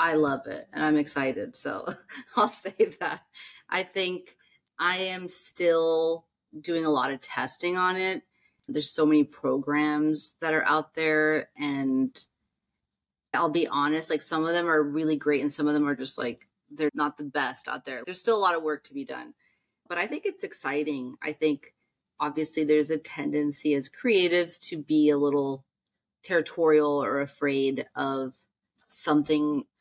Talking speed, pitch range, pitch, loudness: 170 wpm, 145-165 Hz, 150 Hz, -27 LUFS